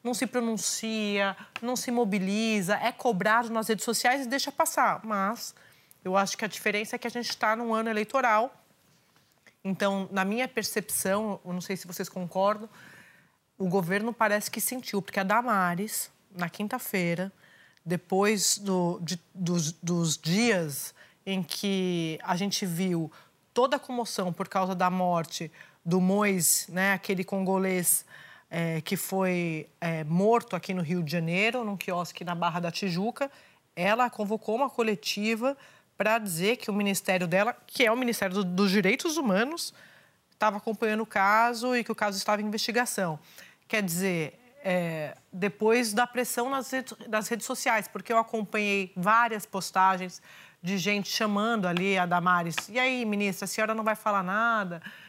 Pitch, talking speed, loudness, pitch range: 205 Hz, 160 wpm, -28 LUFS, 185-225 Hz